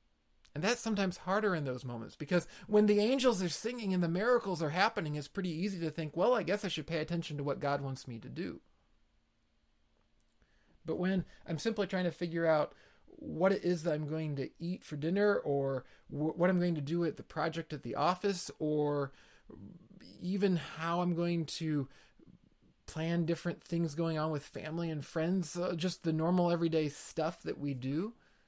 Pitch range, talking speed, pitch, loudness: 145-180 Hz, 190 wpm, 165 Hz, -34 LUFS